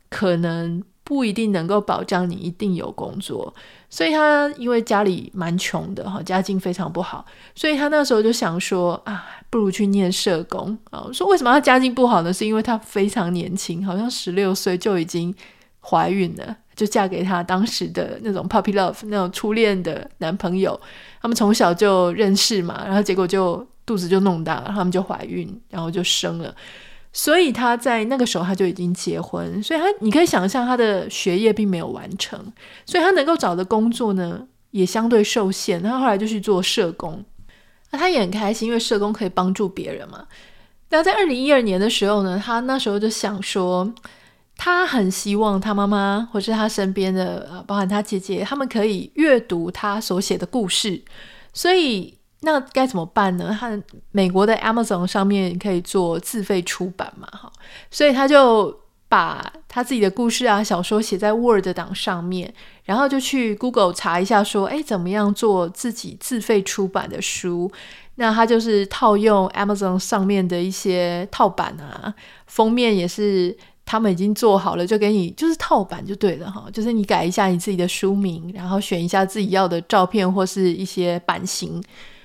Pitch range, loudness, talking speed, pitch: 185-225 Hz, -20 LUFS, 295 characters per minute, 205 Hz